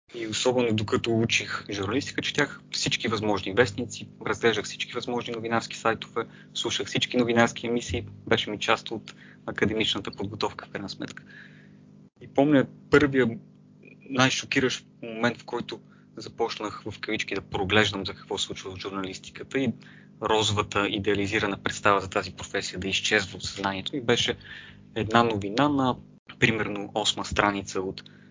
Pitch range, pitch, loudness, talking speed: 100-120 Hz, 110 Hz, -26 LUFS, 135 wpm